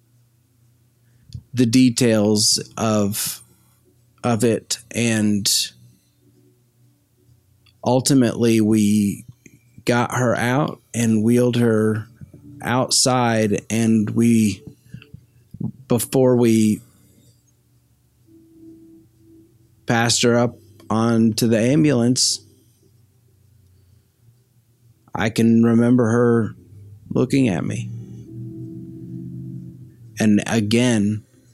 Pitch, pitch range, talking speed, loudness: 115 Hz, 105-120 Hz, 65 wpm, -18 LUFS